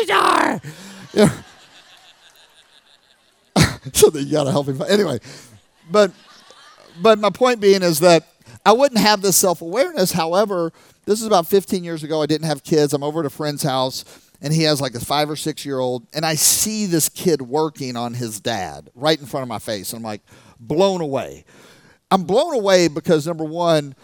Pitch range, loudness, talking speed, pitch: 140-195 Hz, -18 LUFS, 175 wpm, 160 Hz